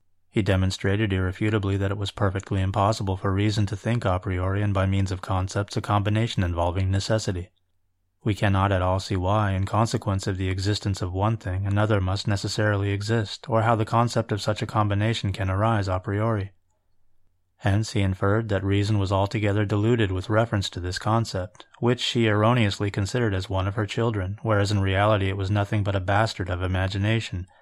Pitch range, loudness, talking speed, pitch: 95-110 Hz, -25 LUFS, 185 wpm, 100 Hz